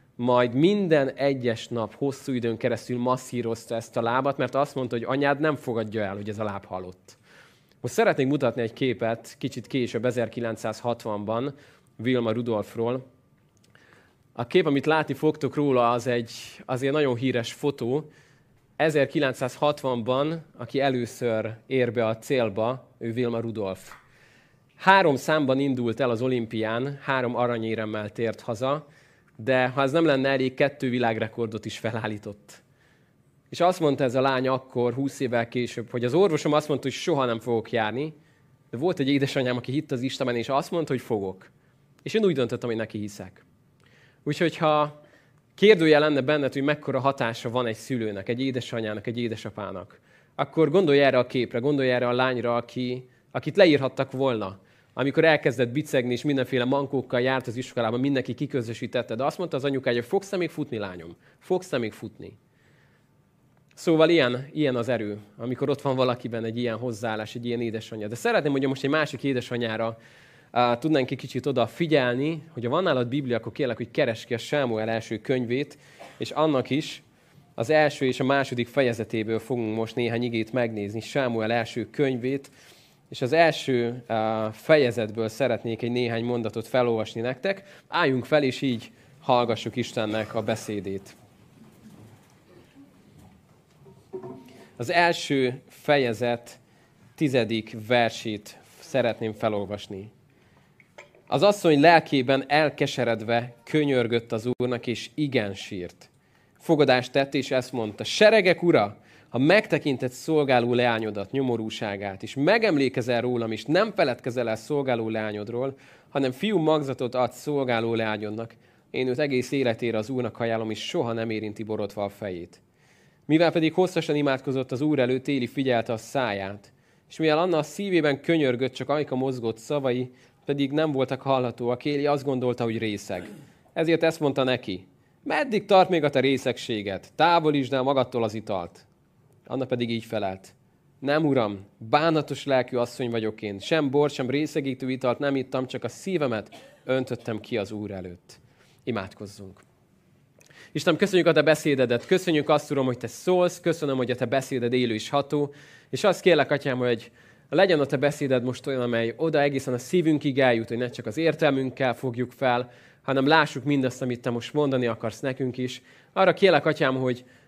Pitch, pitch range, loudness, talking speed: 125 Hz, 115-145 Hz, -25 LUFS, 155 wpm